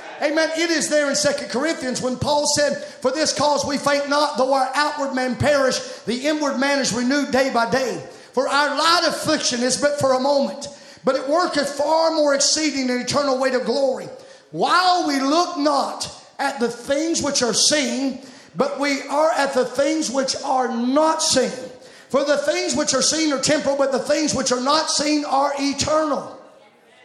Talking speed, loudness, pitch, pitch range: 190 wpm, -20 LUFS, 280 Hz, 265-295 Hz